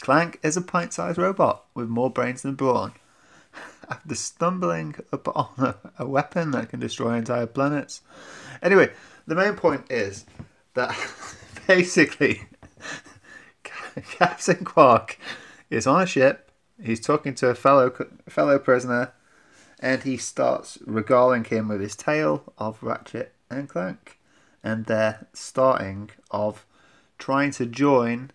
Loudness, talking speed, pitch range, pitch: -23 LUFS, 125 wpm, 115-140 Hz, 125 Hz